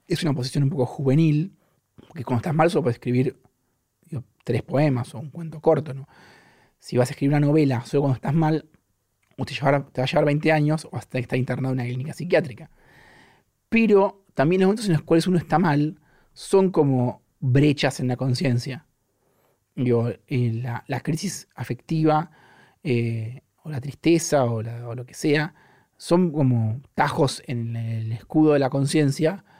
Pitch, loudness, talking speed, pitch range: 140 Hz, -23 LUFS, 175 wpm, 125-155 Hz